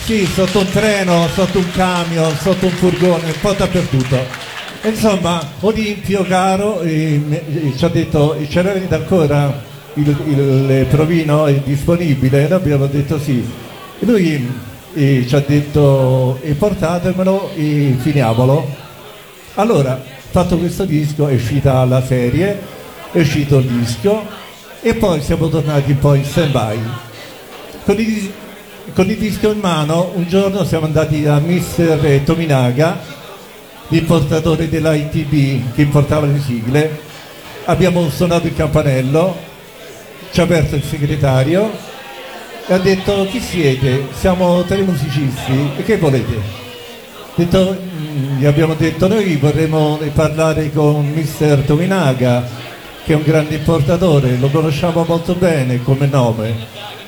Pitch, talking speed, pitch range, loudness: 155 Hz, 130 wpm, 140-180 Hz, -15 LUFS